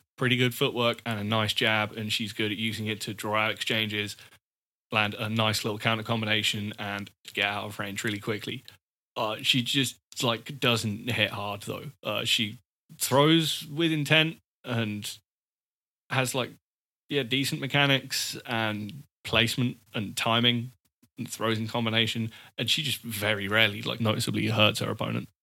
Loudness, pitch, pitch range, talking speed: -27 LUFS, 115 Hz, 105-125 Hz, 160 wpm